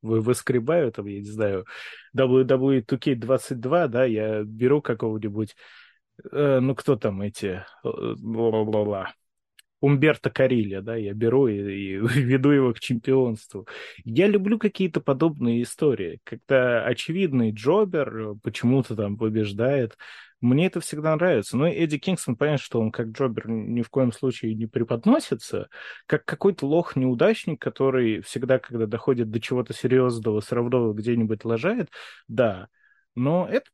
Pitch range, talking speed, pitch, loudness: 110-140 Hz, 135 wpm, 125 Hz, -24 LUFS